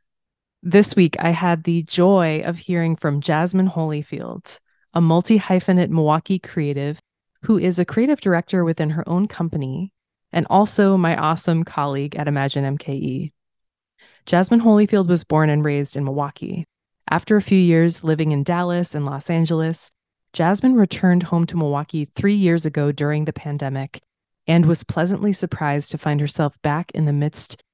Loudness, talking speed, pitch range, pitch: -19 LUFS, 160 wpm, 150-180 Hz, 165 Hz